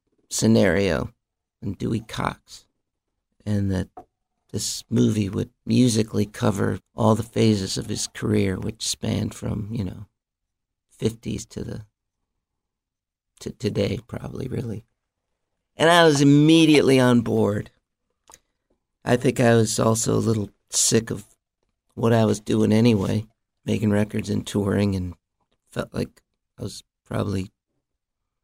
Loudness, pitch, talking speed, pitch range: -22 LUFS, 110 Hz, 125 wpm, 100-115 Hz